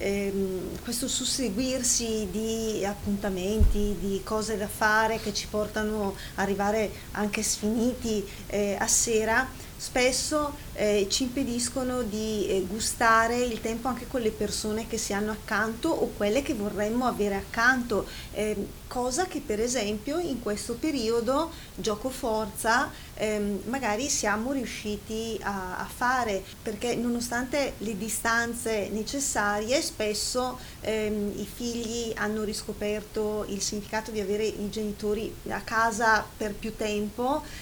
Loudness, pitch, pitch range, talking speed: -28 LUFS, 220 Hz, 210-240 Hz, 130 wpm